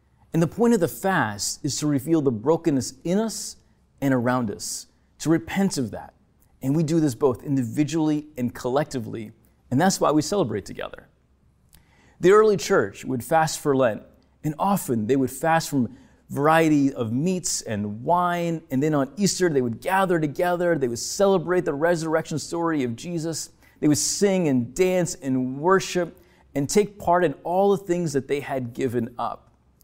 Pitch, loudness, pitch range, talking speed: 150 Hz, -23 LUFS, 130-175 Hz, 175 wpm